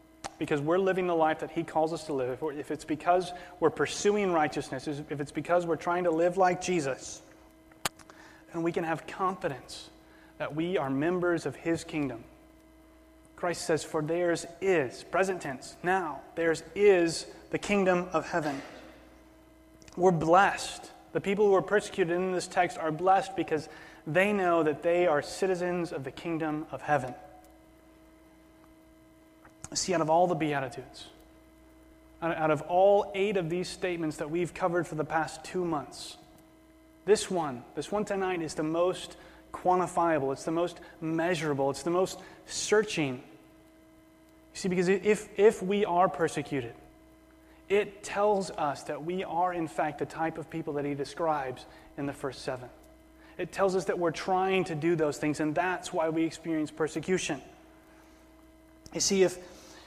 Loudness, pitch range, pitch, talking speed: -30 LUFS, 155-190 Hz, 170 Hz, 160 wpm